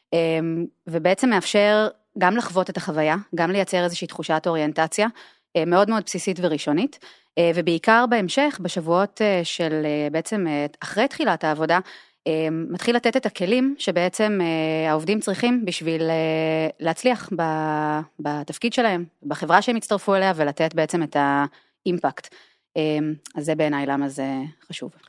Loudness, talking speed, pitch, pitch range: -22 LUFS, 115 wpm, 170 Hz, 160-205 Hz